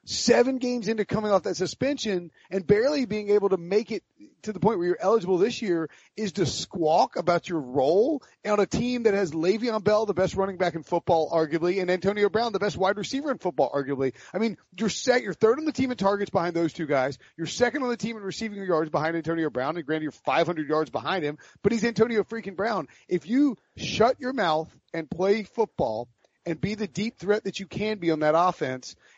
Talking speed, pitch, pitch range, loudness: 225 wpm, 195 Hz, 165-220 Hz, -26 LUFS